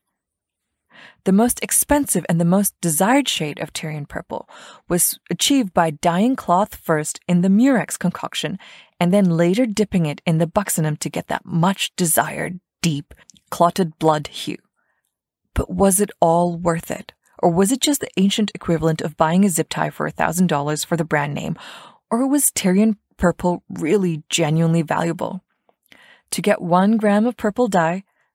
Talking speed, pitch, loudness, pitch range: 165 wpm, 175 Hz, -19 LUFS, 165-205 Hz